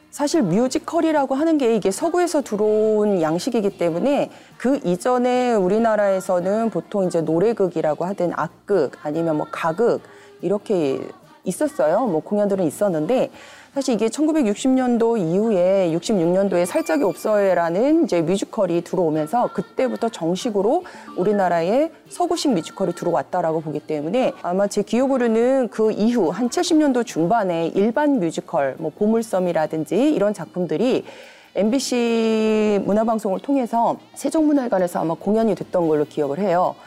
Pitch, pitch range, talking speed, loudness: 215 Hz, 180-265 Hz, 335 characters per minute, -20 LUFS